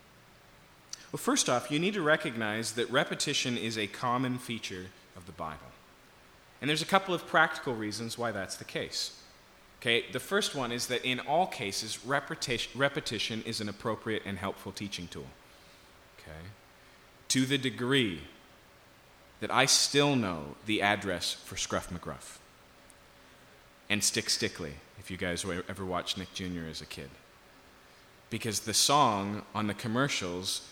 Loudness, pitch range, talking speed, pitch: -31 LUFS, 90-125 Hz, 150 wpm, 105 Hz